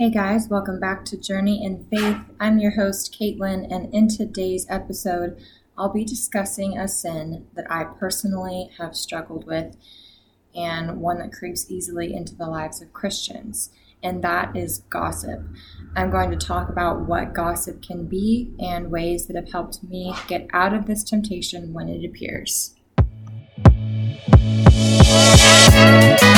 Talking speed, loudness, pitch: 145 wpm, -19 LUFS, 175 Hz